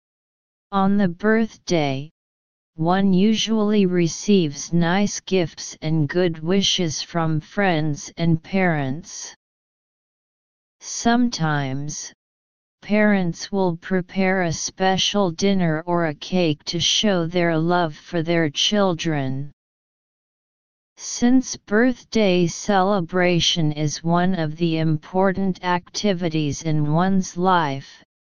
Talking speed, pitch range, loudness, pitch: 95 wpm, 155-195 Hz, -21 LUFS, 175 Hz